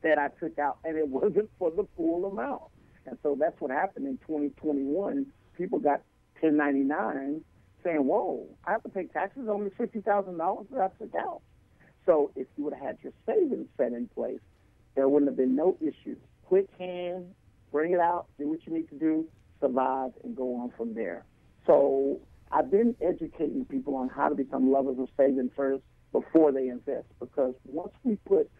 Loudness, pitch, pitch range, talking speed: -29 LUFS, 160 Hz, 135-210 Hz, 185 wpm